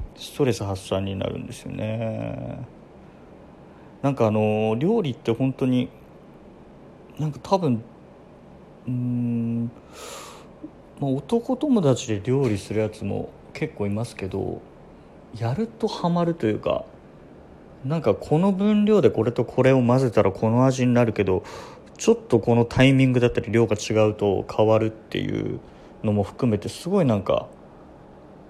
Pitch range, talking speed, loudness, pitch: 110-135 Hz, 270 characters per minute, -23 LUFS, 120 Hz